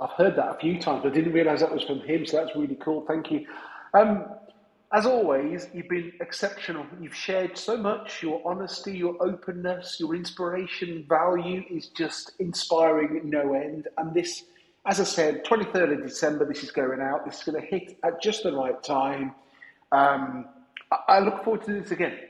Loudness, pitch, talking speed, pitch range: -26 LUFS, 175 Hz, 190 wpm, 155-195 Hz